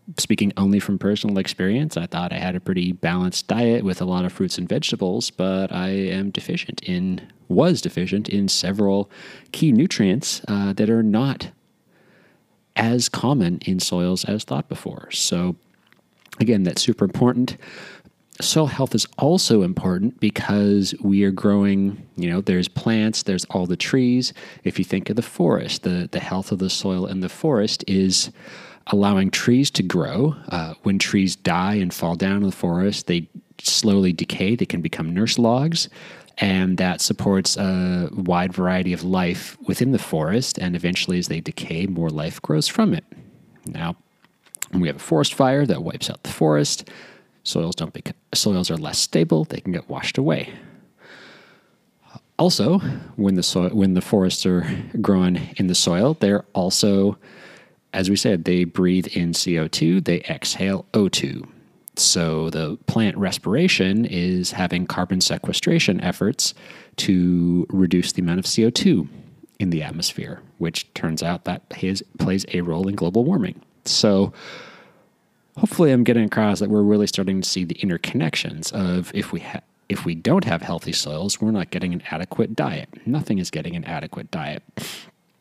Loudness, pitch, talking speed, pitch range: -21 LUFS, 95 Hz, 165 wpm, 90-110 Hz